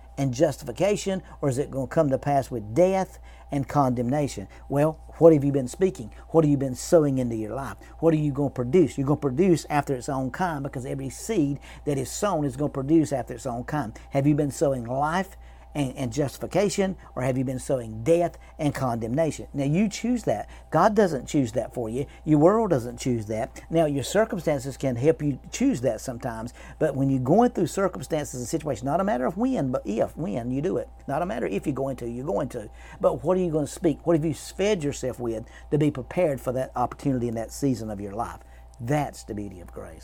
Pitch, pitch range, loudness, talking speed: 140 Hz, 130-165 Hz, -25 LUFS, 230 wpm